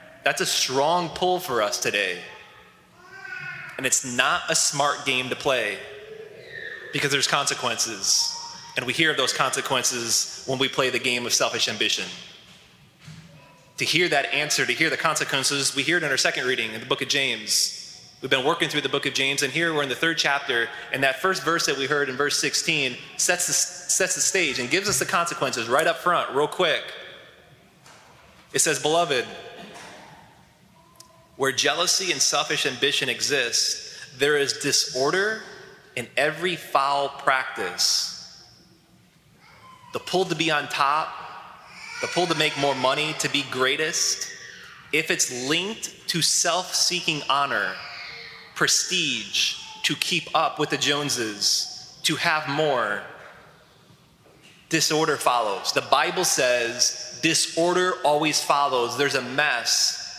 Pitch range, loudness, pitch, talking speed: 140-180 Hz, -22 LUFS, 155 Hz, 150 wpm